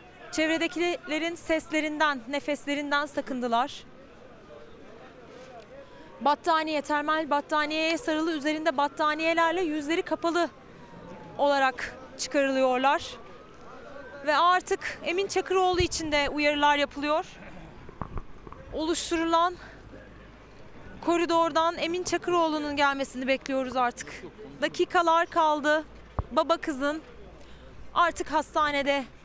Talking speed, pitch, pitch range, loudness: 70 wpm, 310 Hz, 290-335 Hz, -27 LUFS